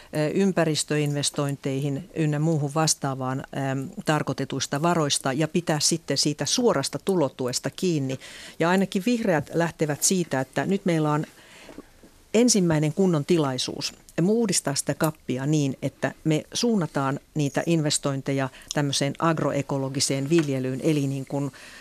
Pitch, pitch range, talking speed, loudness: 150 Hz, 140-170 Hz, 115 wpm, -25 LUFS